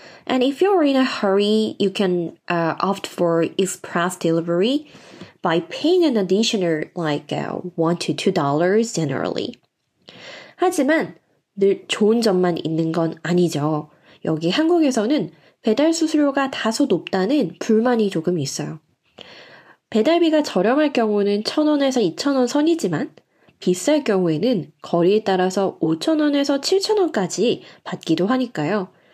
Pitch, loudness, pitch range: 200 Hz, -20 LUFS, 170-275 Hz